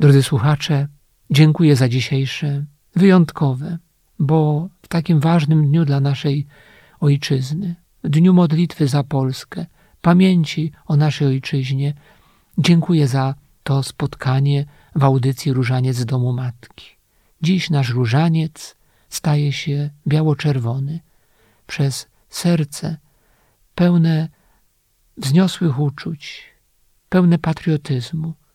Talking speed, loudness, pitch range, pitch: 95 wpm, -18 LUFS, 135-160 Hz, 145 Hz